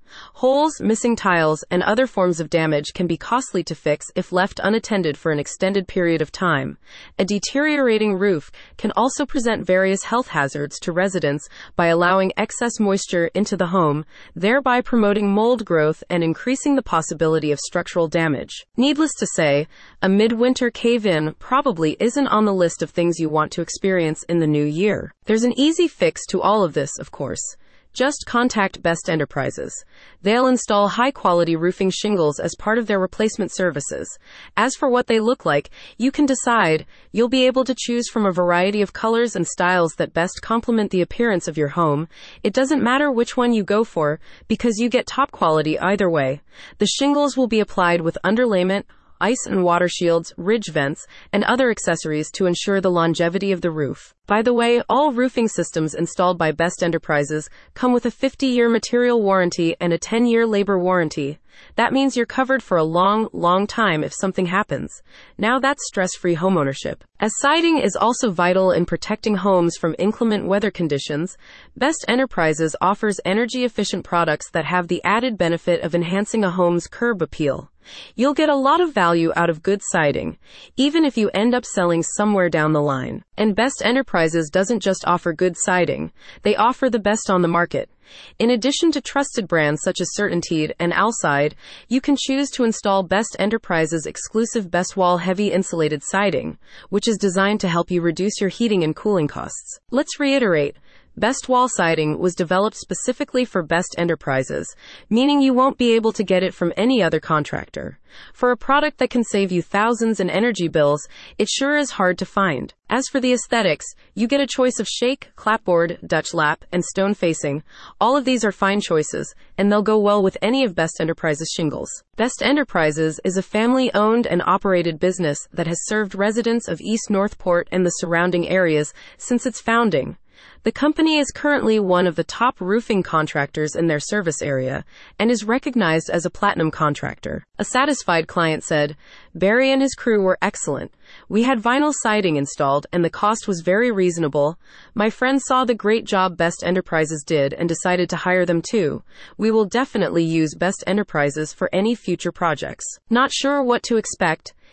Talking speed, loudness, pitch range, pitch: 185 wpm, -20 LUFS, 170-235 Hz, 195 Hz